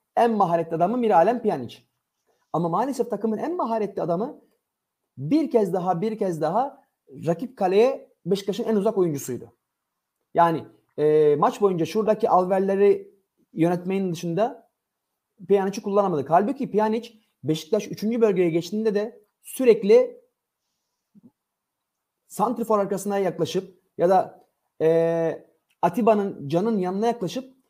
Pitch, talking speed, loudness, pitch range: 200 Hz, 110 wpm, -23 LUFS, 170-225 Hz